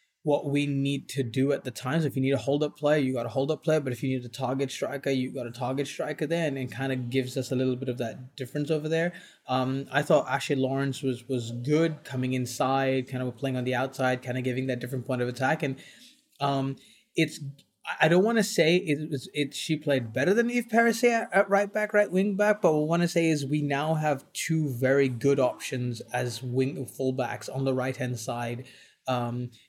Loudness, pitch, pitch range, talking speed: -28 LUFS, 135 Hz, 130-155 Hz, 240 wpm